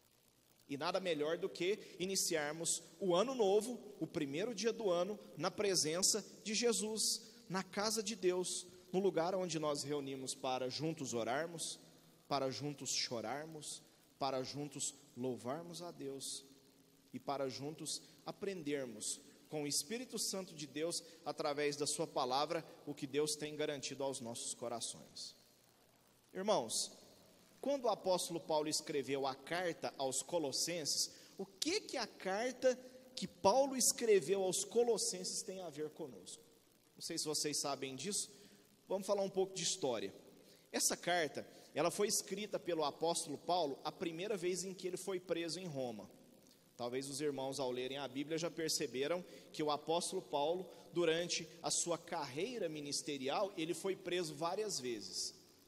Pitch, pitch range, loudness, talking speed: 165 Hz, 145-190 Hz, -39 LUFS, 150 wpm